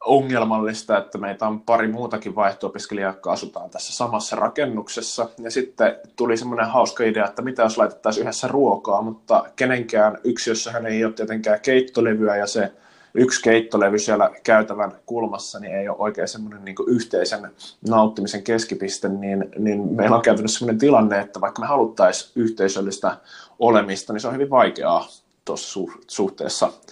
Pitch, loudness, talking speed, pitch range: 110 Hz, -21 LUFS, 155 wpm, 100-115 Hz